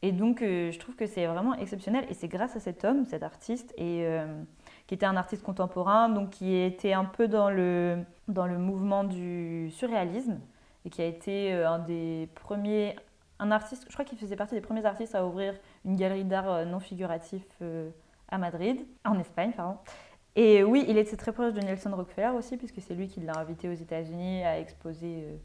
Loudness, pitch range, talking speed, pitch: -30 LUFS, 175-215 Hz, 210 wpm, 190 Hz